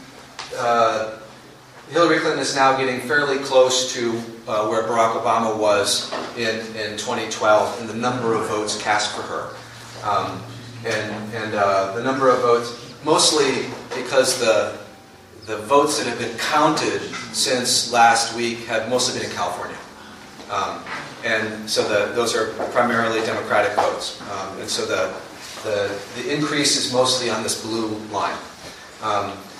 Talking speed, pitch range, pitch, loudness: 150 wpm, 110-125 Hz, 115 Hz, -20 LUFS